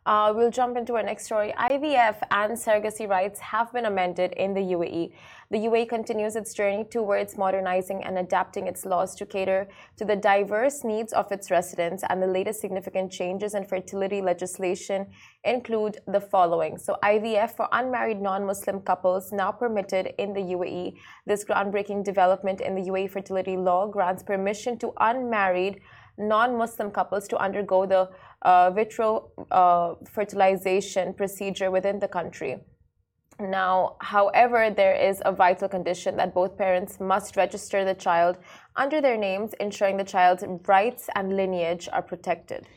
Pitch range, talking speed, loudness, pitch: 185-210 Hz, 155 wpm, -25 LUFS, 195 Hz